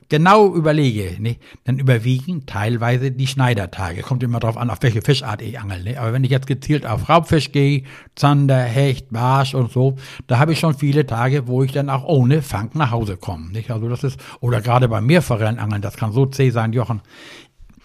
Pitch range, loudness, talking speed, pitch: 115-140 Hz, -18 LUFS, 210 wpm, 130 Hz